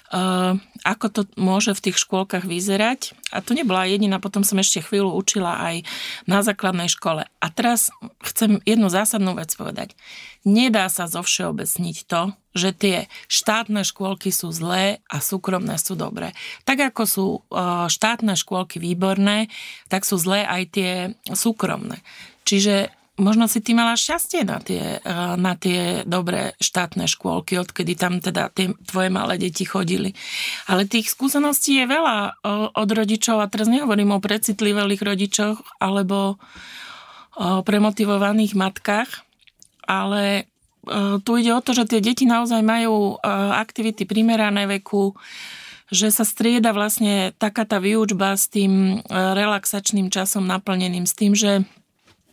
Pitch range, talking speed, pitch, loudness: 190-220 Hz, 140 wpm, 200 Hz, -20 LUFS